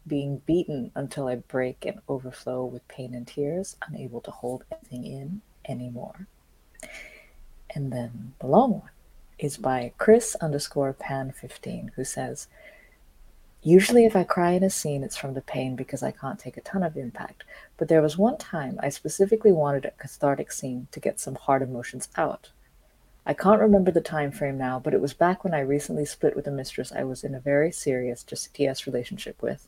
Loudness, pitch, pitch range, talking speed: -26 LUFS, 140 Hz, 130-175 Hz, 190 wpm